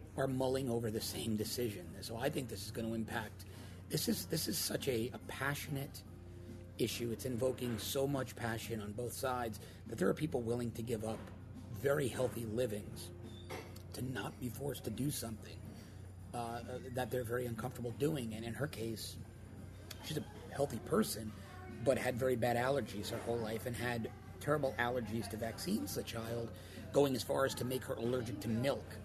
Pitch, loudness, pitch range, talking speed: 115 Hz, -39 LUFS, 105-125 Hz, 185 wpm